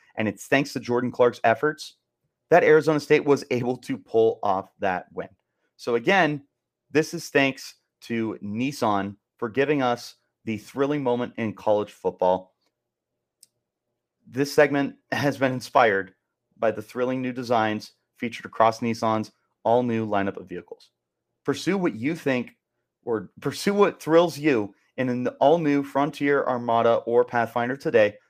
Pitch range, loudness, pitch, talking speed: 115-145 Hz, -24 LUFS, 125 Hz, 145 wpm